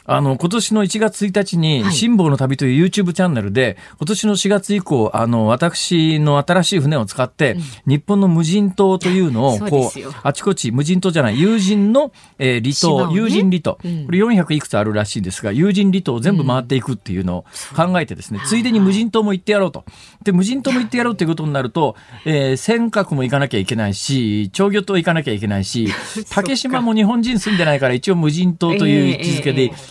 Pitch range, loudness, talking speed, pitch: 130-200 Hz, -17 LUFS, 410 characters per minute, 170 Hz